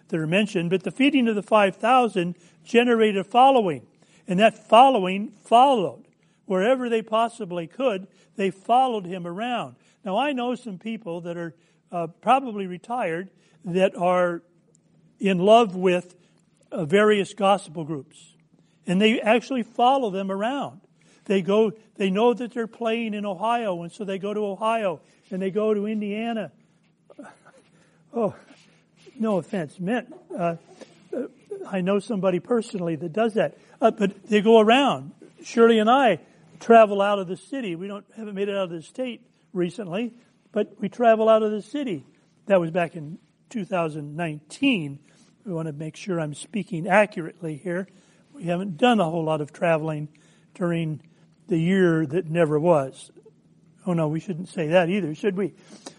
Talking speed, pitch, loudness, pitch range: 160 wpm, 195 Hz, -23 LUFS, 175-225 Hz